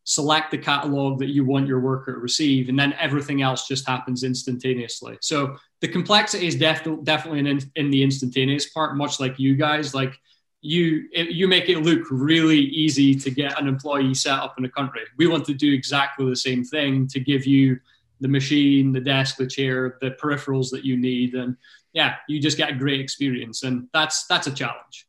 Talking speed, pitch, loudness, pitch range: 205 wpm, 140 Hz, -22 LUFS, 130-150 Hz